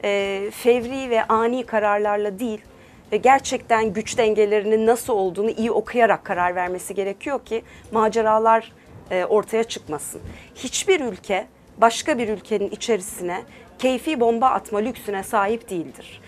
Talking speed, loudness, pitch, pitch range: 120 wpm, -21 LUFS, 220 Hz, 205-235 Hz